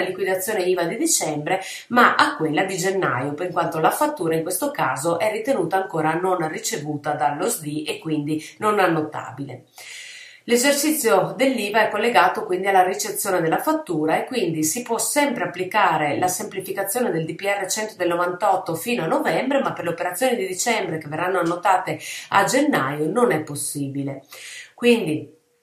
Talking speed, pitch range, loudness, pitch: 155 wpm, 160-225 Hz, -21 LUFS, 185 Hz